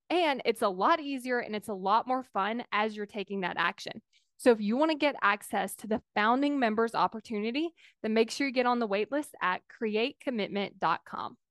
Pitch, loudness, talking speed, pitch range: 225 Hz, -30 LUFS, 200 wpm, 205-265 Hz